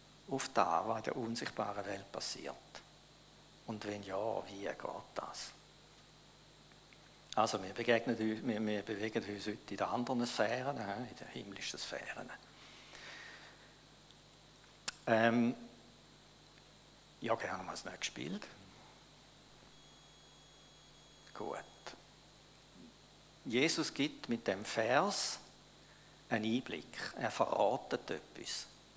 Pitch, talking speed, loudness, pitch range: 115 Hz, 100 wpm, -38 LUFS, 105-120 Hz